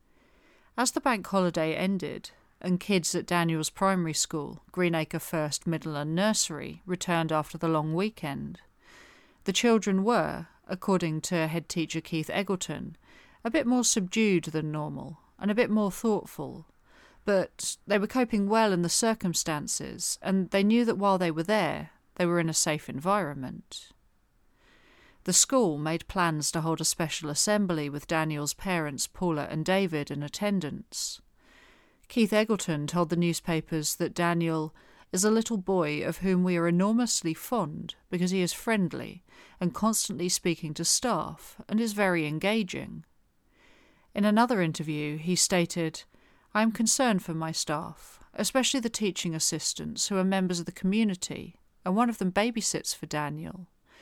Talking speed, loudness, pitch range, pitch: 150 wpm, -28 LUFS, 160-210 Hz, 180 Hz